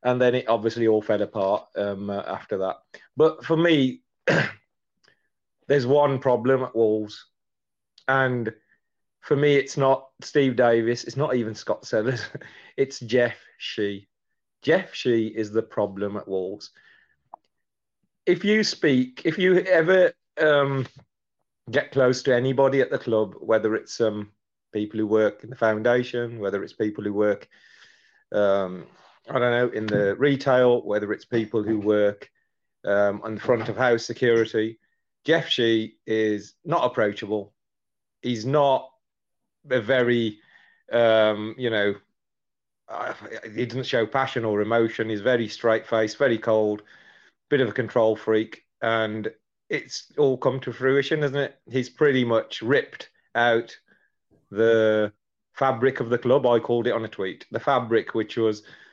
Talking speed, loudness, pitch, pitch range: 145 wpm, -23 LUFS, 115 Hz, 110-130 Hz